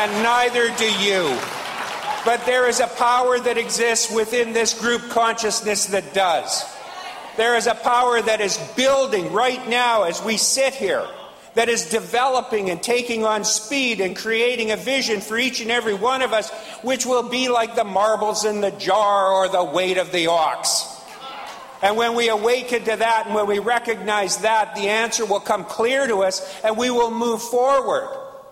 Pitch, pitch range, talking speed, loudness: 230 Hz, 215-240 Hz, 180 wpm, -20 LUFS